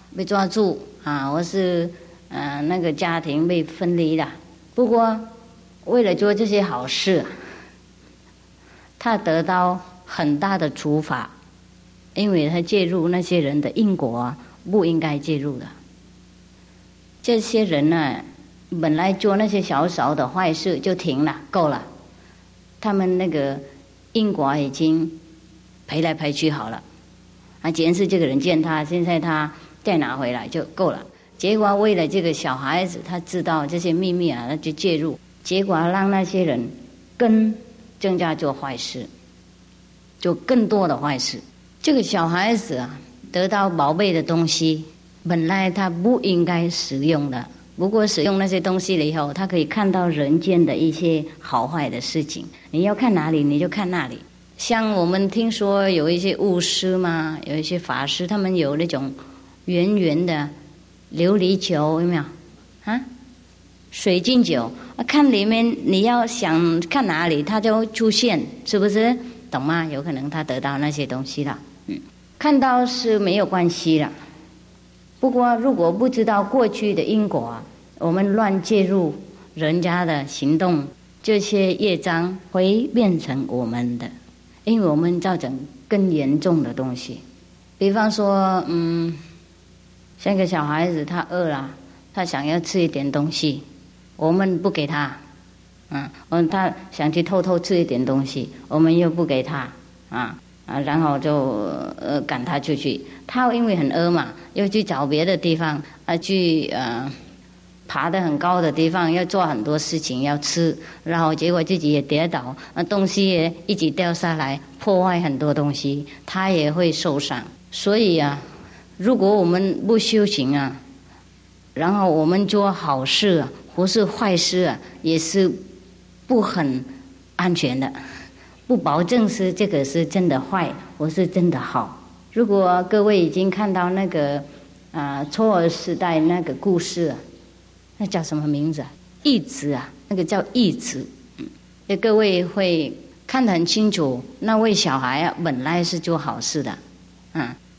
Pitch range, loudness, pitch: 145-195 Hz, -21 LUFS, 170 Hz